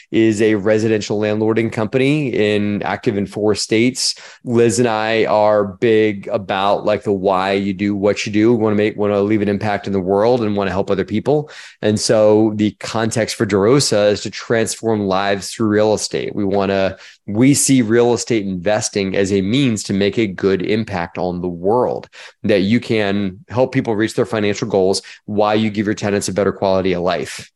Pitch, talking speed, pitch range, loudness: 105 Hz, 205 wpm, 100-110 Hz, -17 LUFS